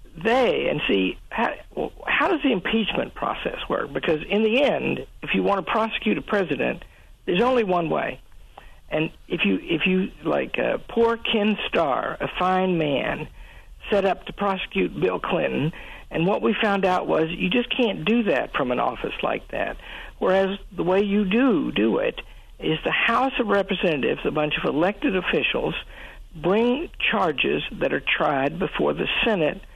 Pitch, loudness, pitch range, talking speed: 205 Hz, -23 LUFS, 185-240 Hz, 175 wpm